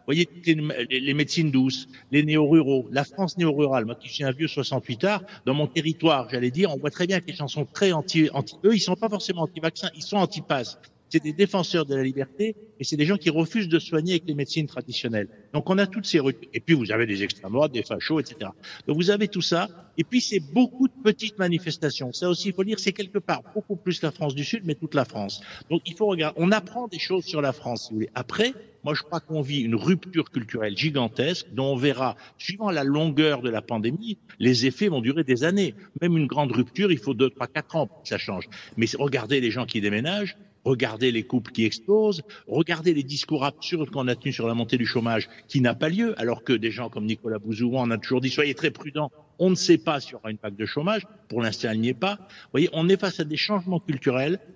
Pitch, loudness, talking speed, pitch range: 150 Hz, -25 LUFS, 245 wpm, 130-180 Hz